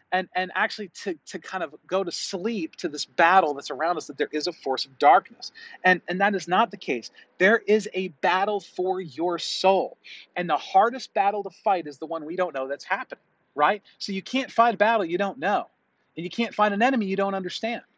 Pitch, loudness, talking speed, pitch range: 195 Hz, -25 LUFS, 235 wpm, 180-215 Hz